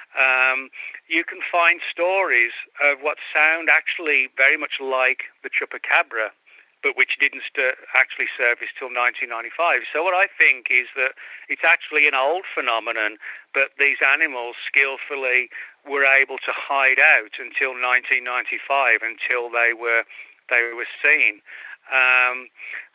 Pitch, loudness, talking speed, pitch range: 130 Hz, -19 LUFS, 135 wpm, 125-145 Hz